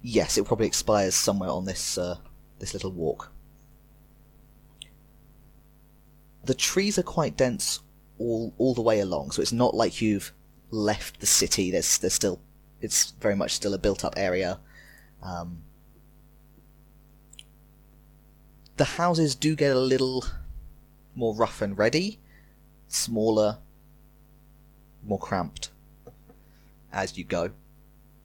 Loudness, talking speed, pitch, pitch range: -26 LUFS, 120 wpm, 90 Hz, 75-115 Hz